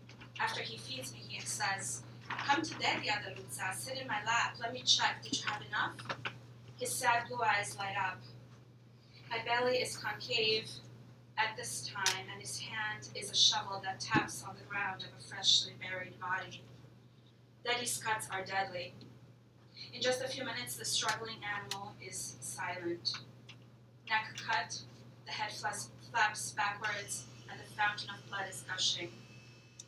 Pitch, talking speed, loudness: 130 Hz, 155 wpm, -35 LUFS